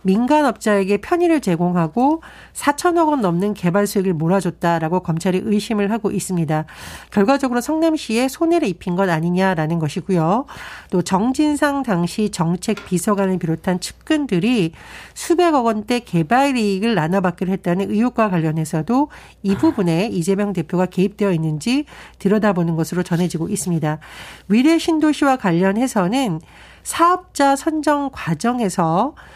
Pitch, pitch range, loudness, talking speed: 200 Hz, 180-265 Hz, -18 LUFS, 335 characters per minute